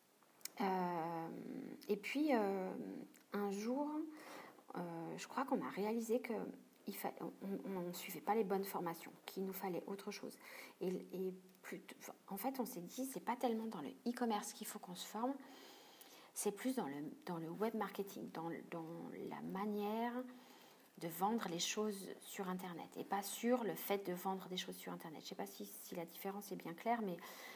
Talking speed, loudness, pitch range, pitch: 195 wpm, -44 LUFS, 180-230 Hz, 200 Hz